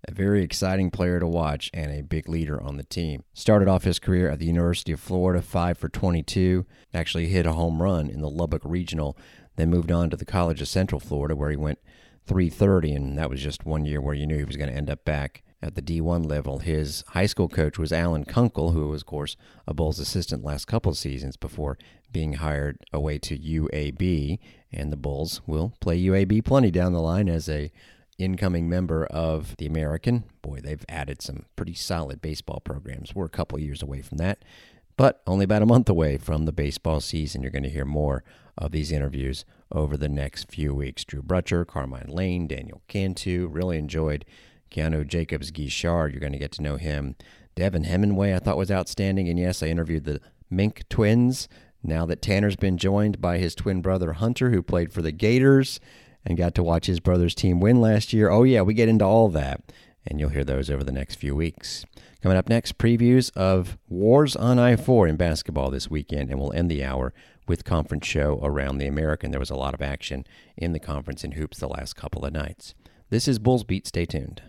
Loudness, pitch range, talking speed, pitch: -25 LUFS, 75-95 Hz, 210 wpm, 85 Hz